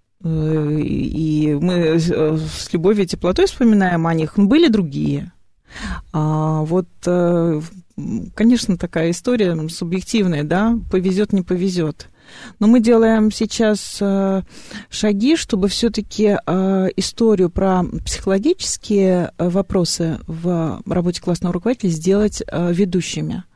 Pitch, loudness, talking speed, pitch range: 185 Hz, -18 LUFS, 95 wpm, 170-210 Hz